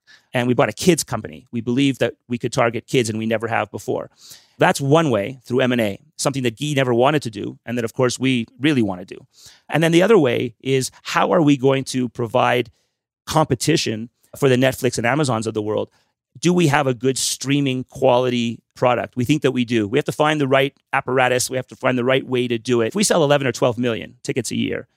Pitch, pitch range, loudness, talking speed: 130 Hz, 120-140 Hz, -19 LUFS, 245 wpm